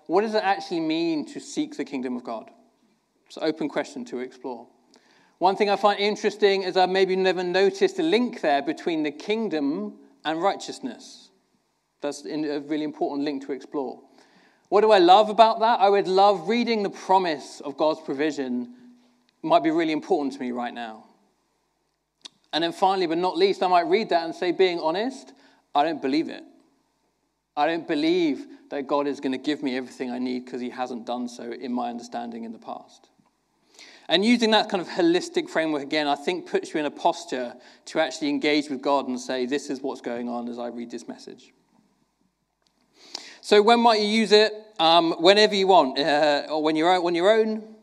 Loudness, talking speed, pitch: -23 LUFS, 200 wpm, 190 Hz